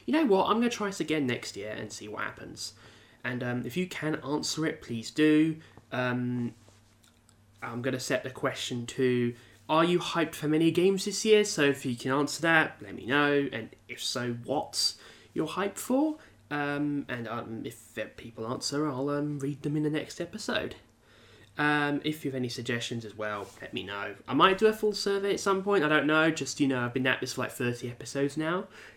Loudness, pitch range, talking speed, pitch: -29 LUFS, 120-155 Hz, 215 wpm, 140 Hz